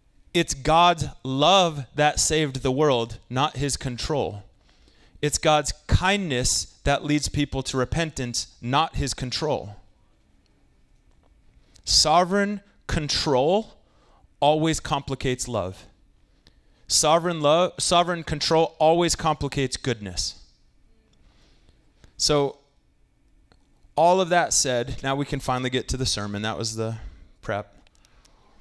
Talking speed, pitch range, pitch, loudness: 105 wpm, 110-155 Hz, 135 Hz, -23 LUFS